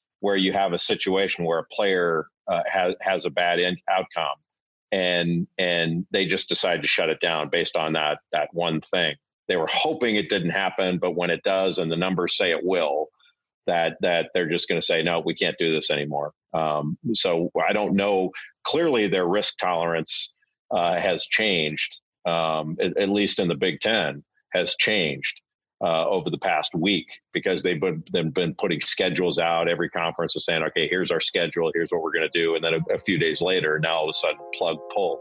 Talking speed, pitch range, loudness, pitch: 210 wpm, 85-95 Hz, -23 LUFS, 90 Hz